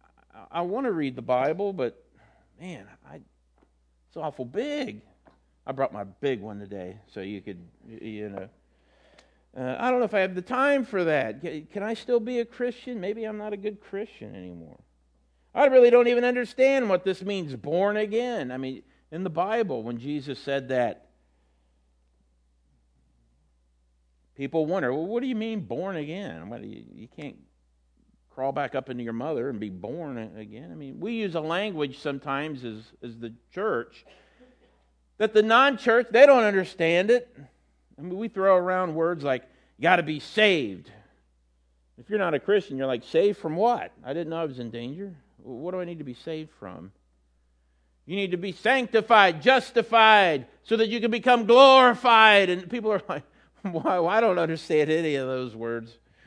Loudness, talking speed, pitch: -24 LUFS, 175 wpm, 160 Hz